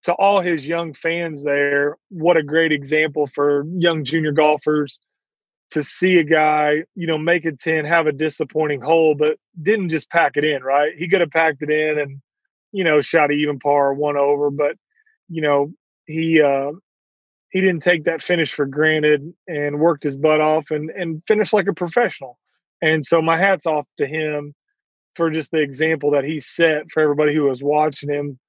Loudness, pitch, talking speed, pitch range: -19 LUFS, 155 Hz, 195 wpm, 150-170 Hz